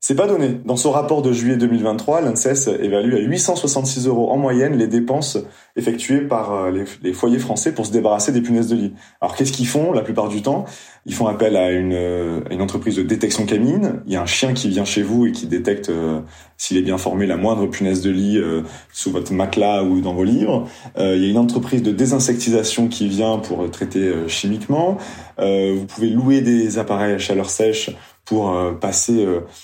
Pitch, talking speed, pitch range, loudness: 110 Hz, 215 wpm, 95-125 Hz, -18 LUFS